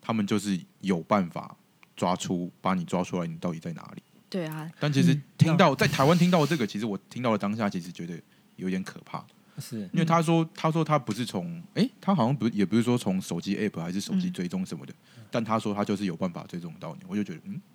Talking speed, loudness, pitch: 350 characters per minute, -27 LUFS, 155 Hz